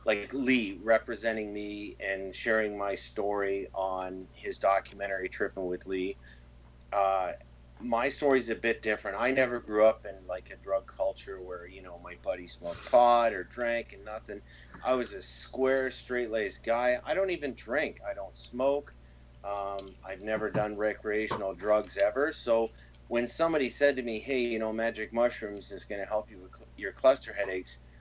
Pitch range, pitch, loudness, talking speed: 95-120 Hz, 105 Hz, -31 LUFS, 175 wpm